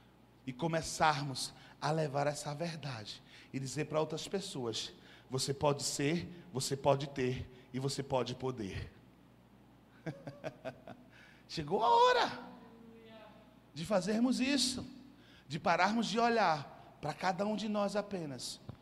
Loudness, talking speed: -35 LUFS, 120 wpm